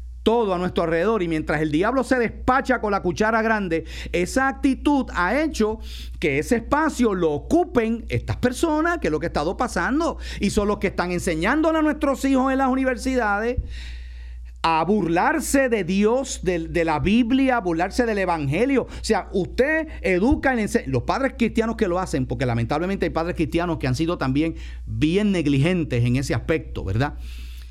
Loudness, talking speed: -22 LUFS, 180 wpm